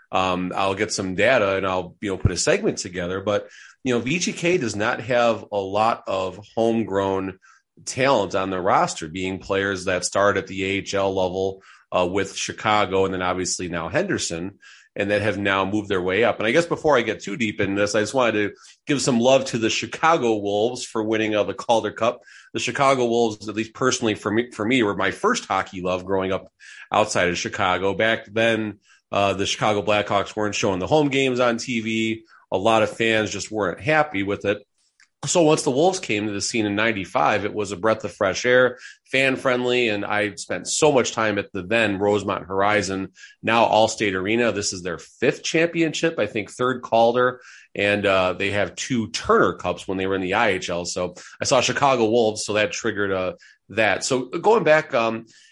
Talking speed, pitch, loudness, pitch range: 205 wpm, 105 Hz, -22 LUFS, 95-115 Hz